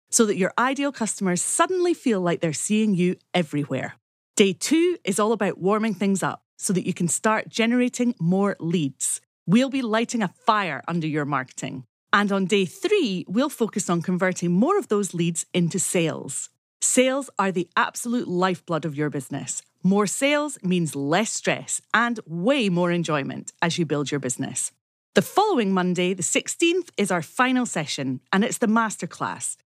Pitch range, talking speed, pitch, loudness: 170-230 Hz, 170 wpm, 190 Hz, -23 LUFS